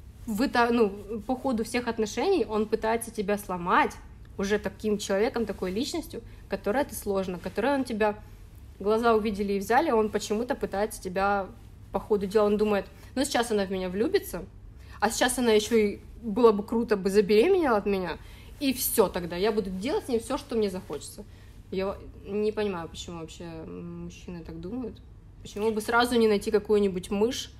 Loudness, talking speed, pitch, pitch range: -27 LUFS, 170 wpm, 210 Hz, 195-230 Hz